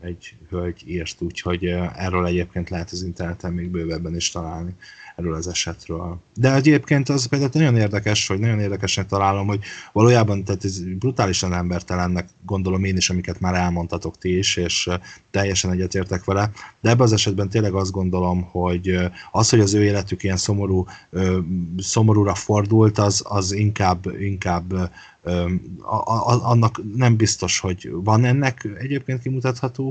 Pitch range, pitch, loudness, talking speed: 90-110 Hz, 95 Hz, -21 LUFS, 150 wpm